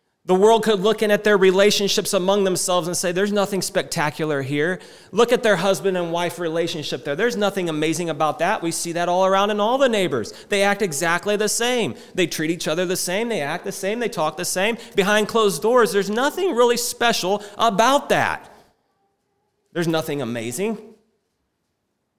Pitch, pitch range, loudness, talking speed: 195 Hz, 175-215 Hz, -20 LUFS, 185 wpm